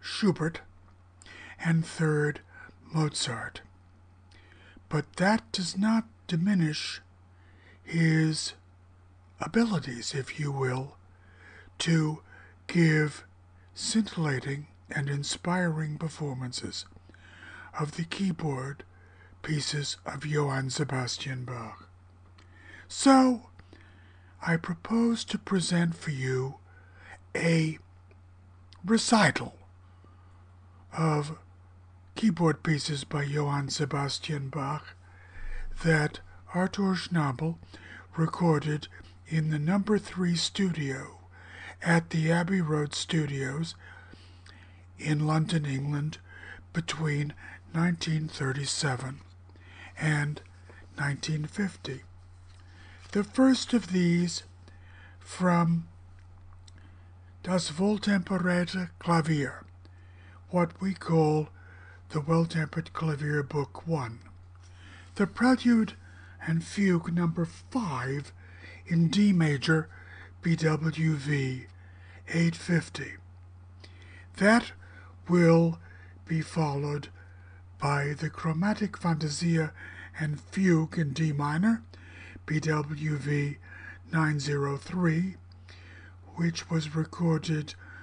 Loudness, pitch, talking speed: -29 LUFS, 140 Hz, 75 wpm